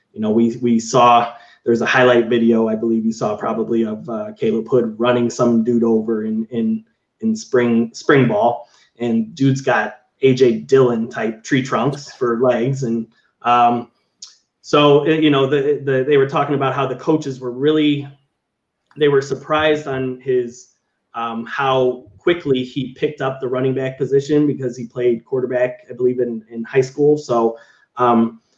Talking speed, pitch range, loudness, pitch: 170 wpm, 115-135 Hz, -17 LUFS, 125 Hz